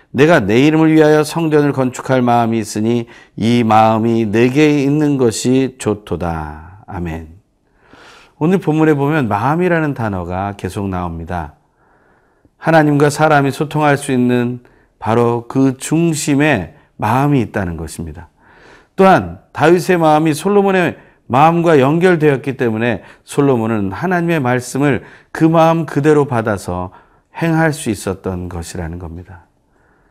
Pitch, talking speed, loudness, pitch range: 125 Hz, 285 characters per minute, -14 LUFS, 100-150 Hz